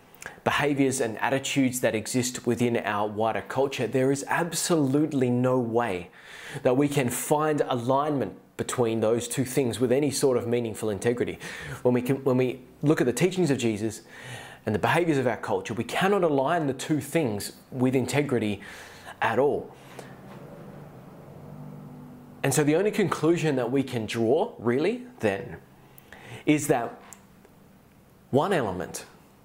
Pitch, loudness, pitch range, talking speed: 130 Hz, -26 LUFS, 120-150 Hz, 145 wpm